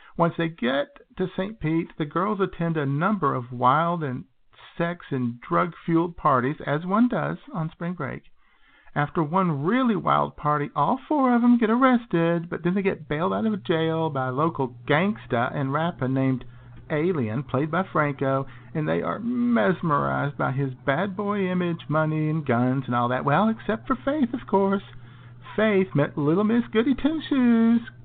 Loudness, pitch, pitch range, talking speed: -24 LUFS, 165 Hz, 140-205 Hz, 180 wpm